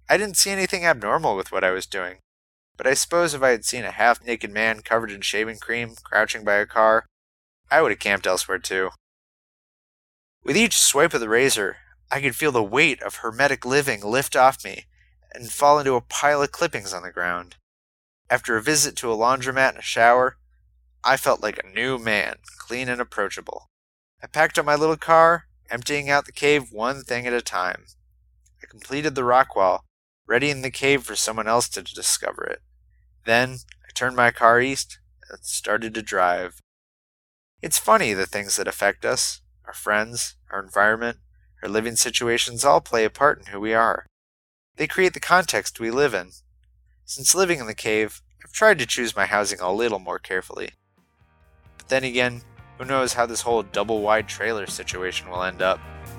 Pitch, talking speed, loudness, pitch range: 115 Hz, 190 wpm, -21 LUFS, 95-130 Hz